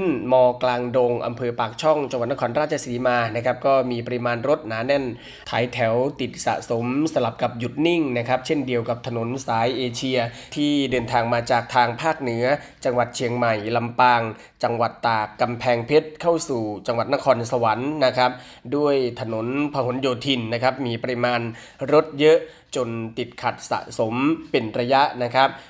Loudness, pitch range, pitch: -22 LUFS, 120-140 Hz, 125 Hz